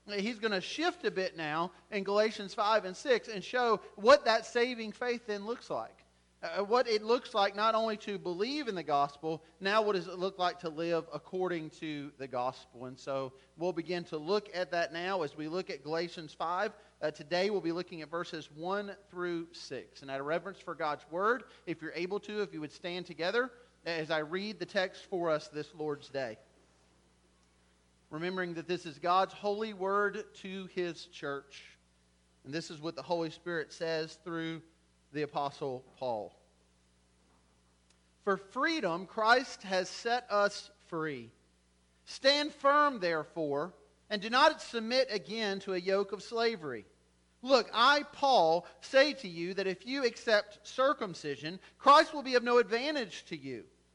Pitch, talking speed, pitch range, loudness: 180 Hz, 175 wpm, 155-210 Hz, -33 LUFS